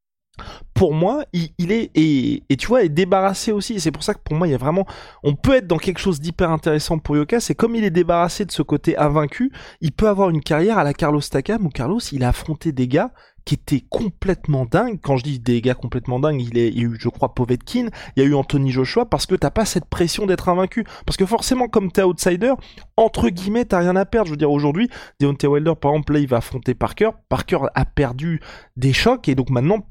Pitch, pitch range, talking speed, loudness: 160 Hz, 140-195 Hz, 250 wpm, -19 LUFS